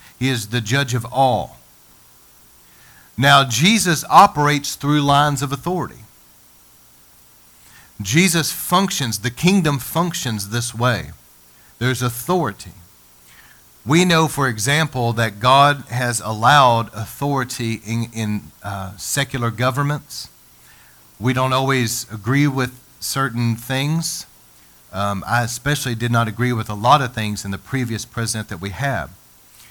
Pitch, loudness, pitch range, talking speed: 120 Hz, -18 LUFS, 100-140 Hz, 125 wpm